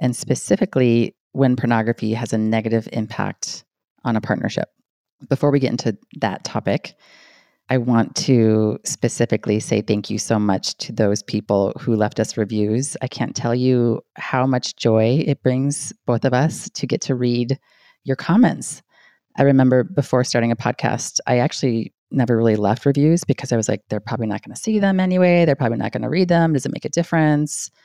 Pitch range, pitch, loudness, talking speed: 110-140 Hz, 125 Hz, -20 LUFS, 185 wpm